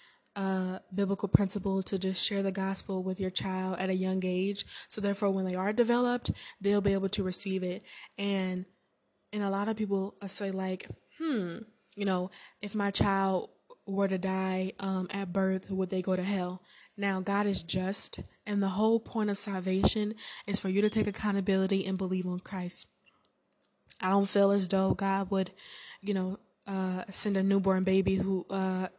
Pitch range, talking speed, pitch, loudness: 190-200 Hz, 180 wpm, 195 Hz, -30 LUFS